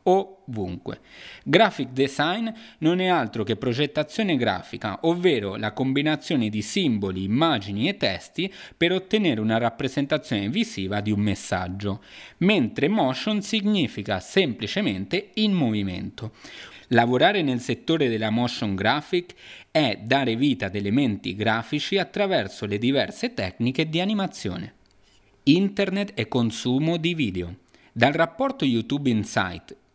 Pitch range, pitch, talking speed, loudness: 105-170 Hz, 130 Hz, 115 wpm, -24 LUFS